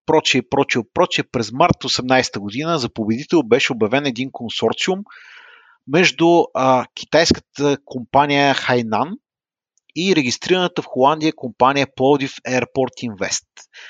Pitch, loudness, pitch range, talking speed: 135 Hz, -18 LUFS, 125-155 Hz, 105 wpm